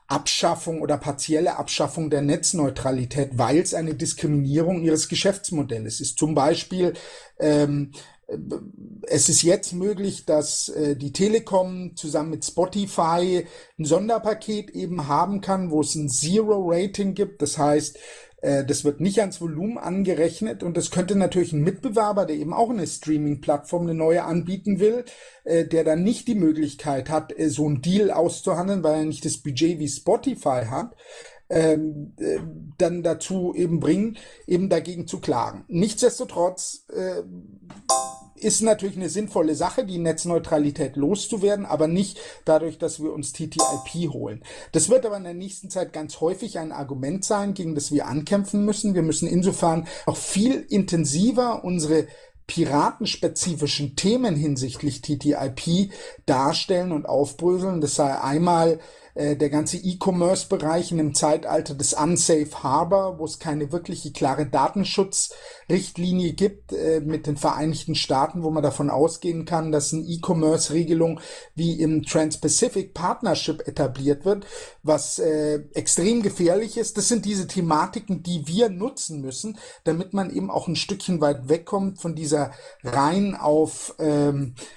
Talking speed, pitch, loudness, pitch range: 140 wpm, 165 Hz, -23 LUFS, 150-195 Hz